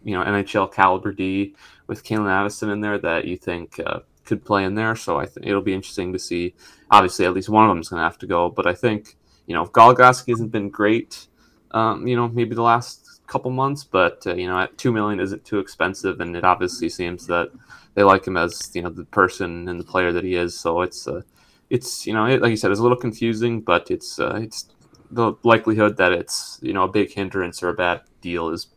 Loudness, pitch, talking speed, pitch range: -20 LUFS, 100 Hz, 245 wpm, 90-115 Hz